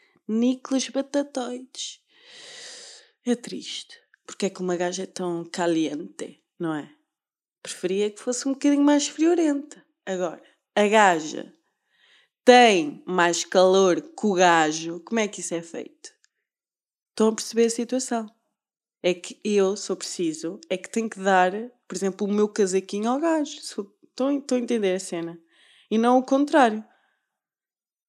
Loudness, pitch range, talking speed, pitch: -23 LUFS, 185-275 Hz, 145 wpm, 220 Hz